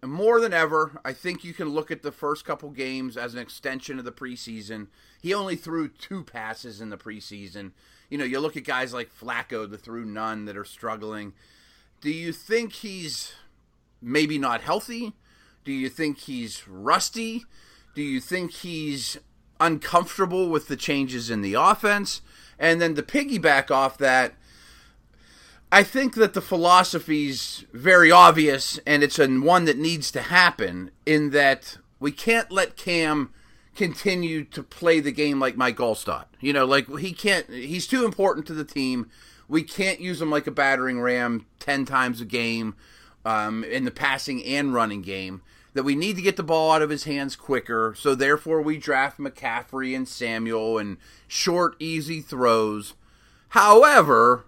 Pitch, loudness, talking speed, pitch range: 145 Hz, -22 LUFS, 170 wpm, 120-170 Hz